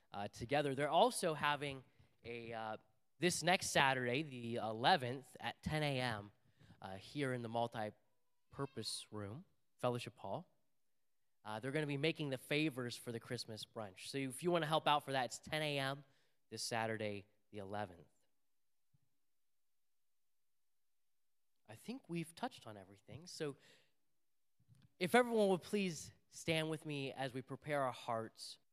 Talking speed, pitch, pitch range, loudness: 150 wpm, 130 Hz, 110-150 Hz, -40 LUFS